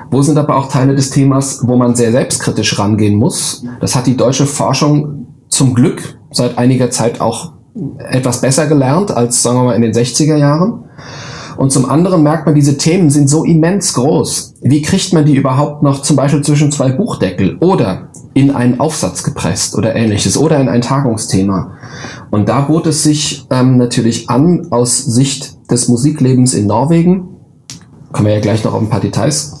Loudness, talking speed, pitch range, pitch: -11 LUFS, 185 wpm, 120-150 Hz, 135 Hz